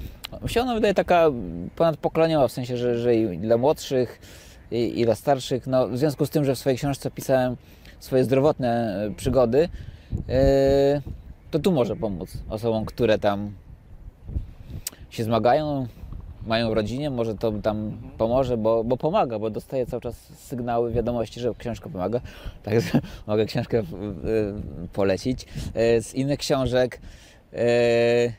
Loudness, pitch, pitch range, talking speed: -24 LUFS, 120 Hz, 110-130 Hz, 140 wpm